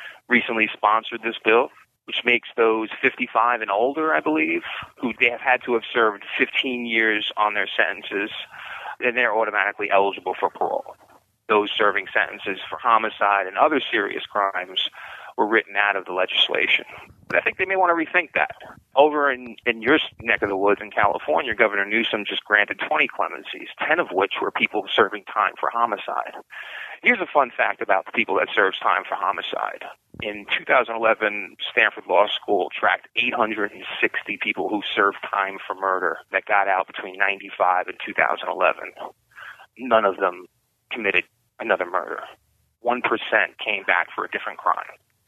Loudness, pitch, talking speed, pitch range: -21 LUFS, 110 Hz, 165 wpm, 100-125 Hz